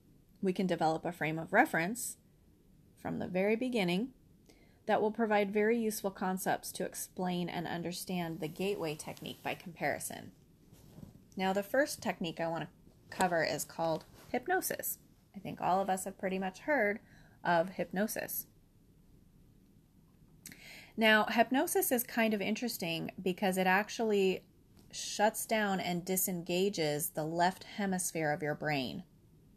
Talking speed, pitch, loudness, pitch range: 135 wpm, 190 Hz, -34 LUFS, 170-215 Hz